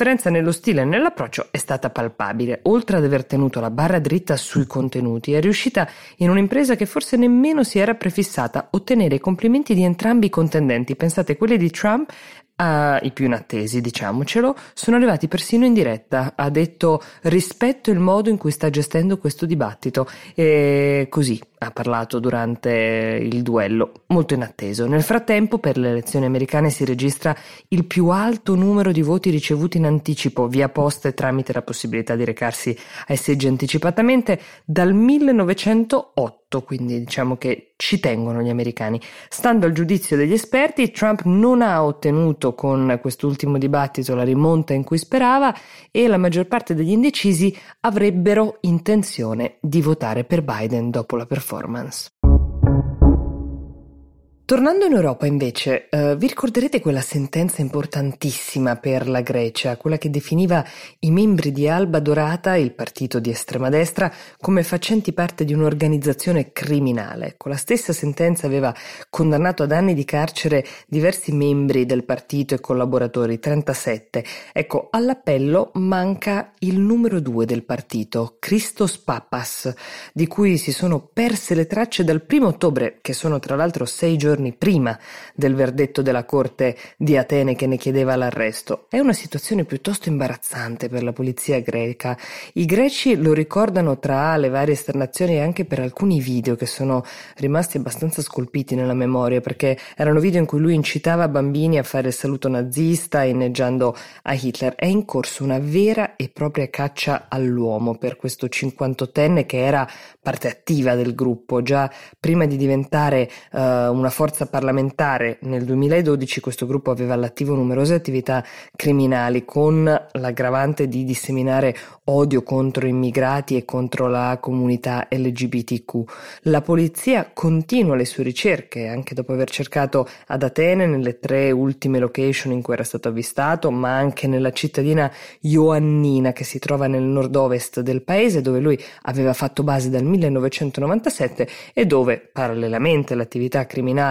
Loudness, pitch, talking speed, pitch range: -20 LUFS, 140 Hz, 150 wpm, 130-170 Hz